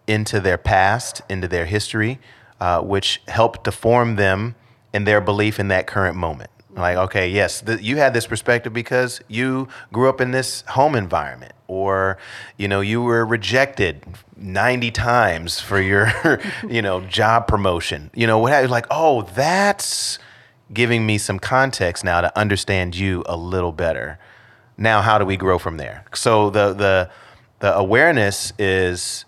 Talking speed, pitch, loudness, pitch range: 165 wpm, 105 Hz, -19 LUFS, 95-120 Hz